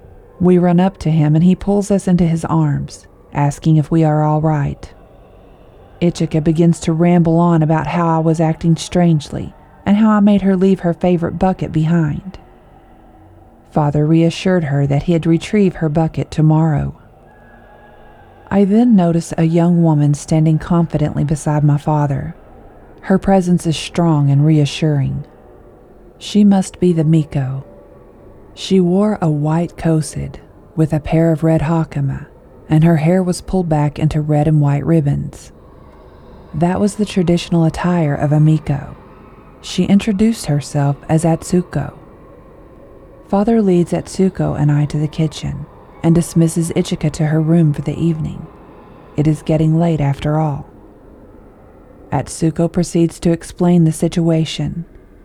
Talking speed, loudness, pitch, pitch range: 145 wpm, -15 LUFS, 160 Hz, 150-175 Hz